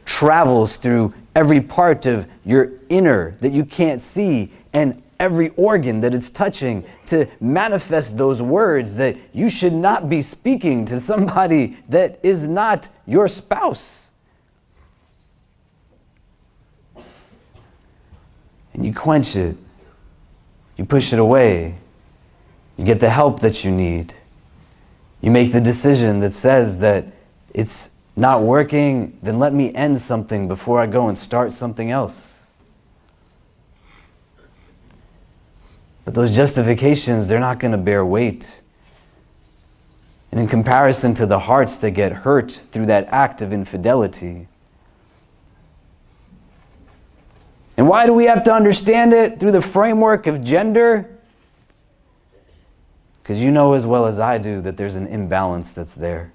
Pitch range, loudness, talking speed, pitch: 100-145 Hz, -17 LUFS, 130 wpm, 120 Hz